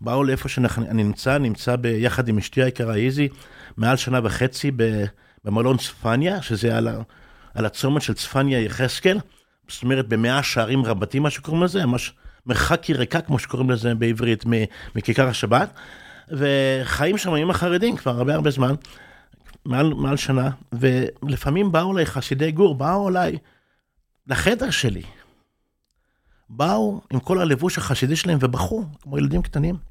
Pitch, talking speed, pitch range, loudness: 130 Hz, 135 wpm, 120-150 Hz, -21 LUFS